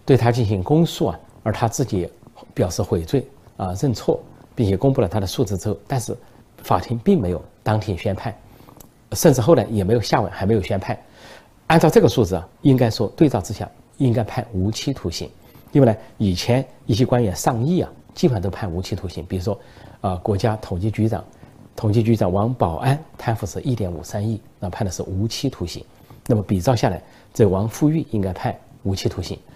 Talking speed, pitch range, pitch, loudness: 295 characters per minute, 100-125 Hz, 110 Hz, -21 LUFS